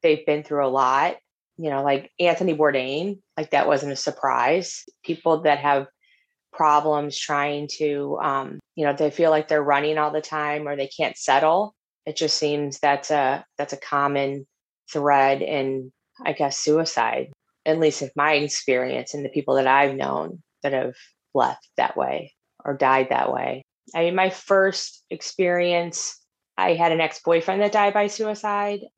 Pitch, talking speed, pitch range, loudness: 150 Hz, 170 wpm, 140-170 Hz, -22 LUFS